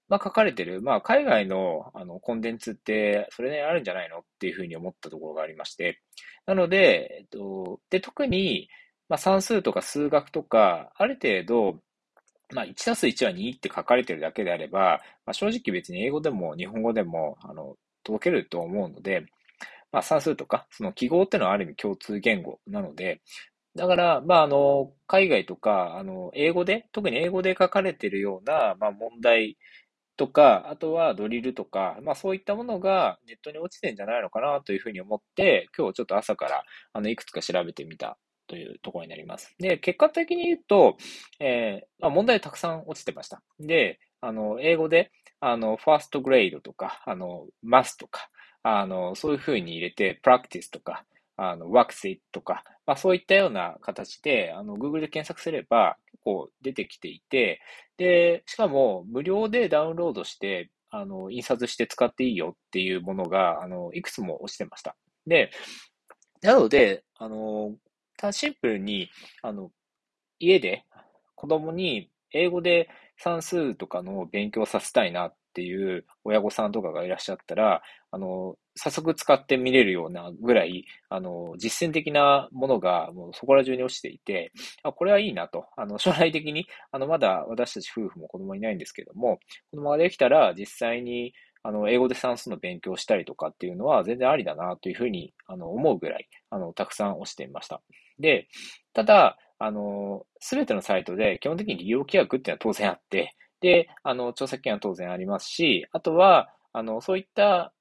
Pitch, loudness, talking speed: 155 Hz, -25 LUFS, 365 characters per minute